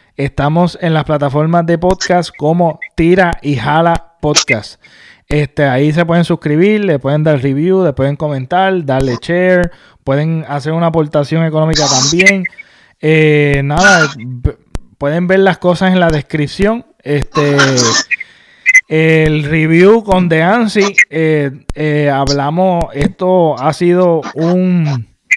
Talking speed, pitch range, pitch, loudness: 125 wpm, 145-180 Hz, 160 Hz, -11 LUFS